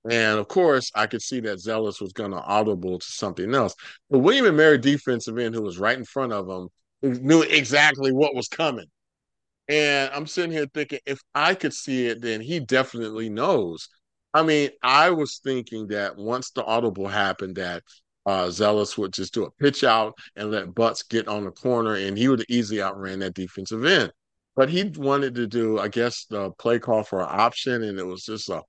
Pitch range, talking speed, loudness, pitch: 105-135 Hz, 205 wpm, -23 LUFS, 115 Hz